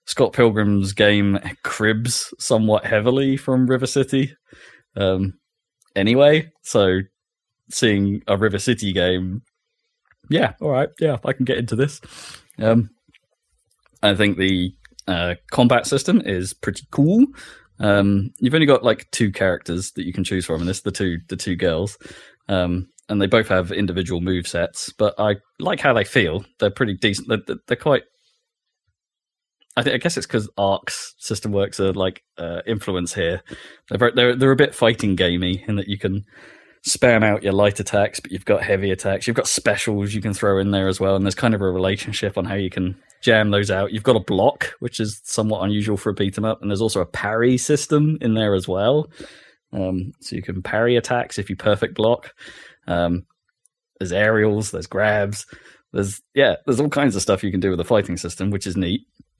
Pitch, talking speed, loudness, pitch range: 105 Hz, 190 wpm, -20 LUFS, 95-120 Hz